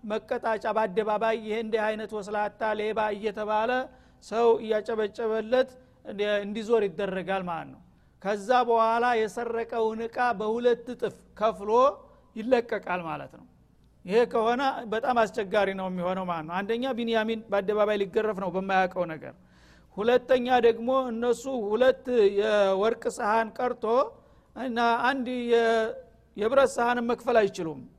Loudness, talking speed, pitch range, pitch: -27 LUFS, 110 wpm, 205-240 Hz, 220 Hz